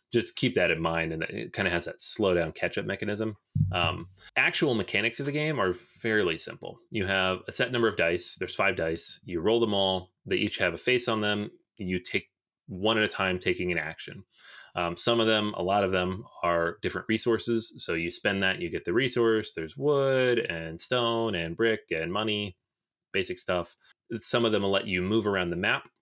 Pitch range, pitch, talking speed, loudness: 90-115 Hz, 105 Hz, 215 wpm, -28 LUFS